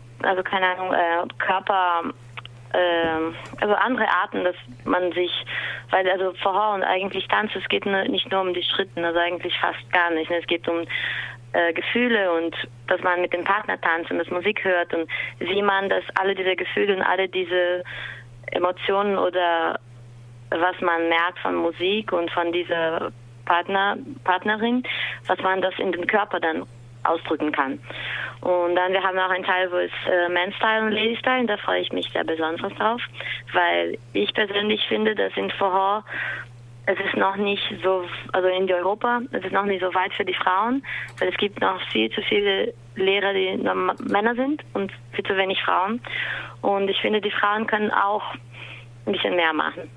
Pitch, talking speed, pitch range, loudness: 180 Hz, 185 wpm, 165-195 Hz, -23 LUFS